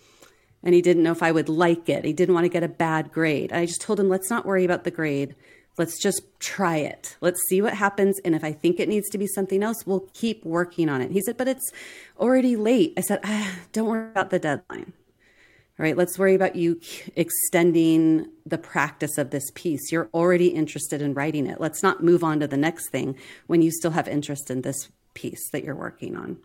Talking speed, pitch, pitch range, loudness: 230 wpm, 170 Hz, 155-190 Hz, -23 LUFS